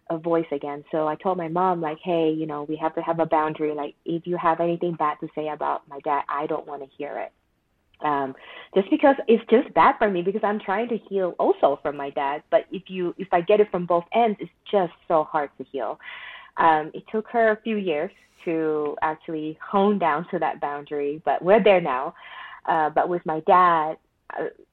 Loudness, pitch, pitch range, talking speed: -24 LUFS, 165 Hz, 155-195 Hz, 225 wpm